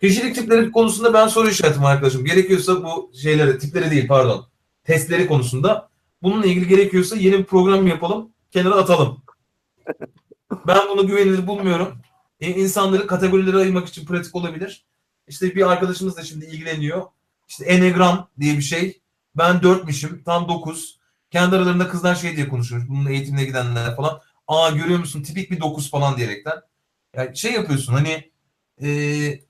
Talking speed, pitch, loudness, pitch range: 150 wpm, 175 Hz, -18 LUFS, 145-190 Hz